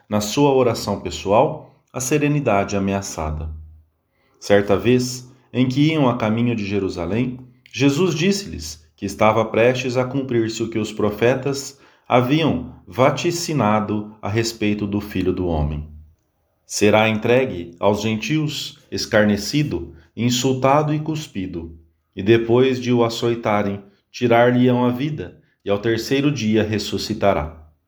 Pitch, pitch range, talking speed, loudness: 110 Hz, 100-130 Hz, 120 wpm, -19 LUFS